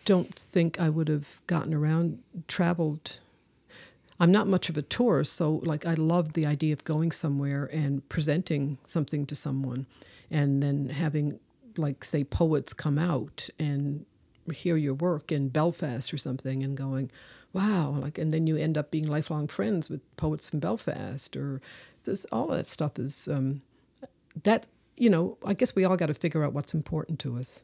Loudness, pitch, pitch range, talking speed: -29 LUFS, 155 Hz, 140-170 Hz, 180 wpm